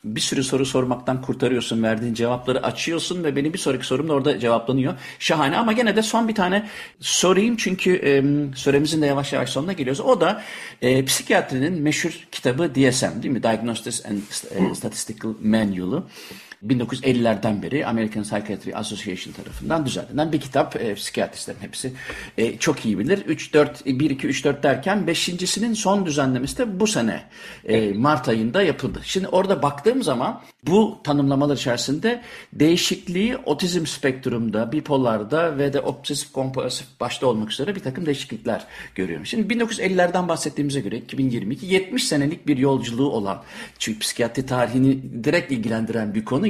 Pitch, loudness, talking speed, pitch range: 140 Hz, -22 LUFS, 145 wpm, 125-175 Hz